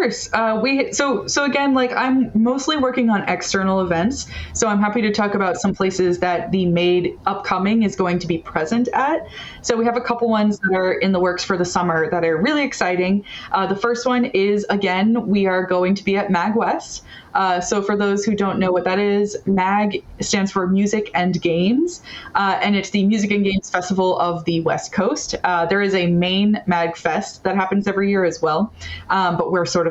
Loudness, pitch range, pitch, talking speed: -19 LUFS, 180-215 Hz, 195 Hz, 215 wpm